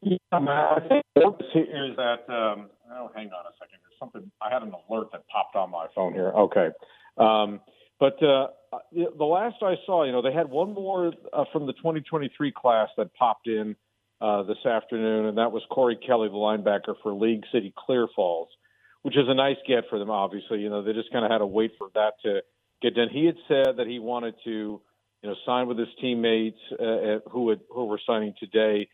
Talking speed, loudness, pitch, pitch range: 210 wpm, -26 LUFS, 115 Hz, 110-145 Hz